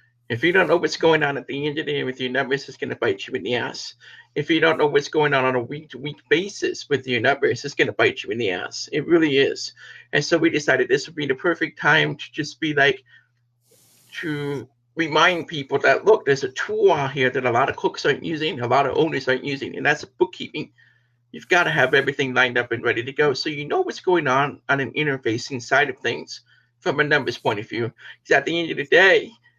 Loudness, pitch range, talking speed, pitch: -21 LUFS, 130-185 Hz, 260 wpm, 150 Hz